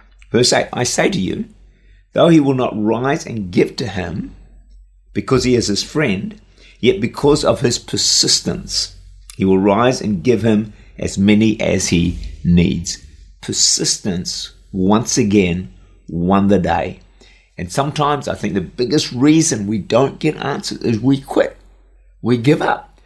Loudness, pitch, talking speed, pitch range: -16 LUFS, 105 Hz, 155 wpm, 95-135 Hz